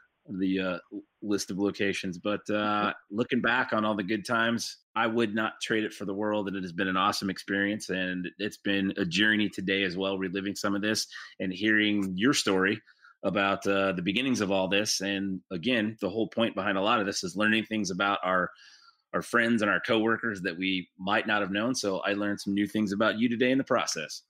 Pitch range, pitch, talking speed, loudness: 95-110 Hz, 100 Hz, 220 wpm, -28 LUFS